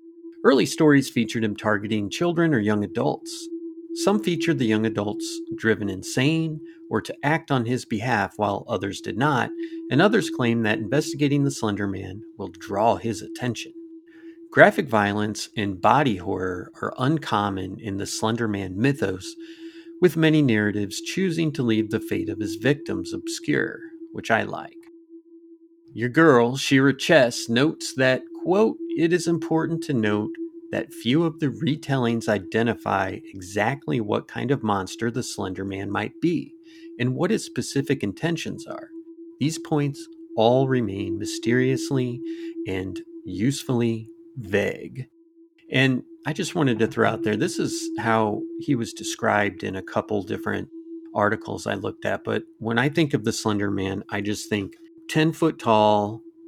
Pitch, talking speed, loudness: 140 Hz, 150 wpm, -24 LUFS